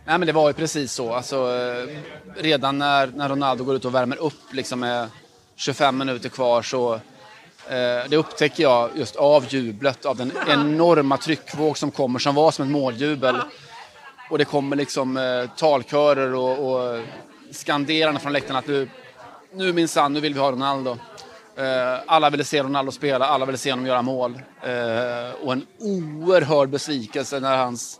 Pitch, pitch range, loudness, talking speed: 140 Hz, 130-150 Hz, -22 LUFS, 170 wpm